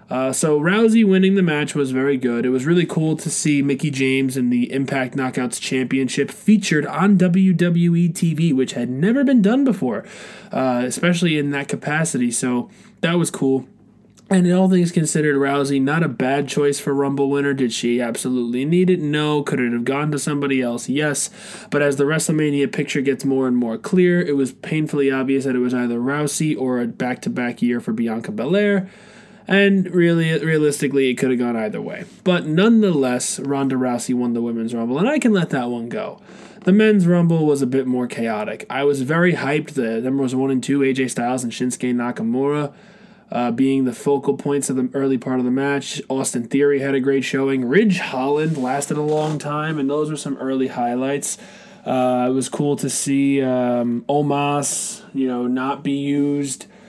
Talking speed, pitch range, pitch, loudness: 195 wpm, 130-165 Hz, 140 Hz, -19 LUFS